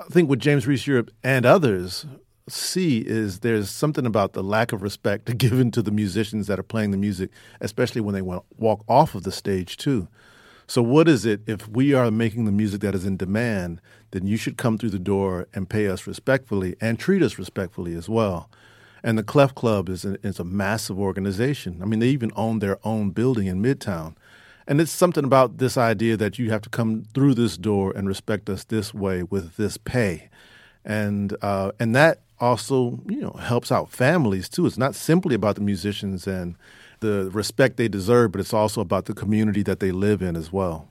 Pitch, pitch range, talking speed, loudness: 105 Hz, 100-120 Hz, 210 wpm, -23 LUFS